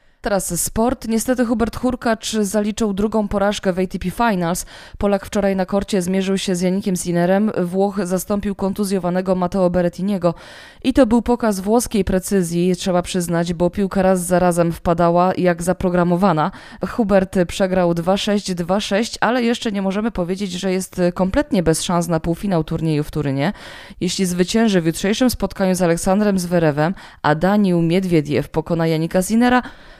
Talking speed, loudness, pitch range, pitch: 150 wpm, -18 LUFS, 175-205 Hz, 190 Hz